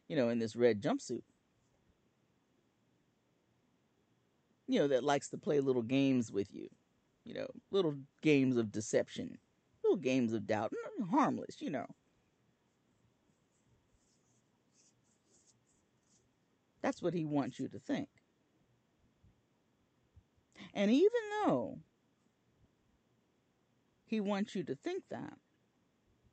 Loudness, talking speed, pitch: -35 LUFS, 105 wpm, 145 Hz